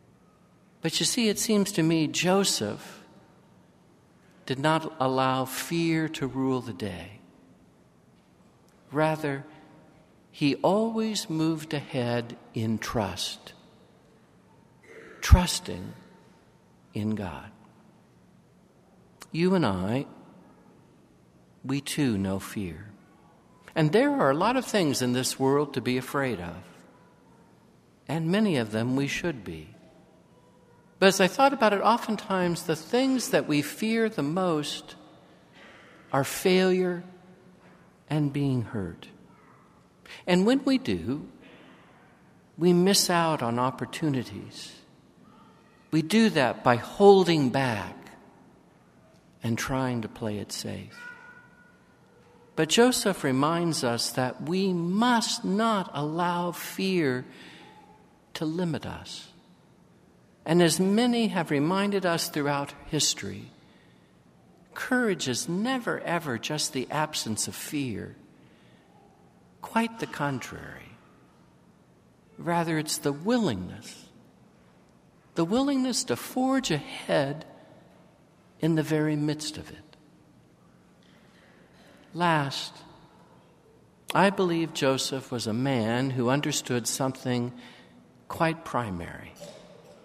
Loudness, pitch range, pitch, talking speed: -27 LUFS, 130-185 Hz, 155 Hz, 105 wpm